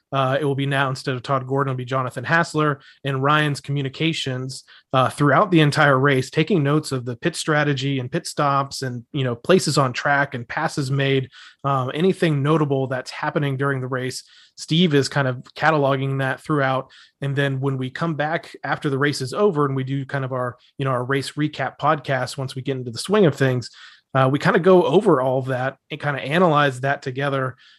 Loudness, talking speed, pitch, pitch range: -21 LUFS, 215 wpm, 140 Hz, 130-150 Hz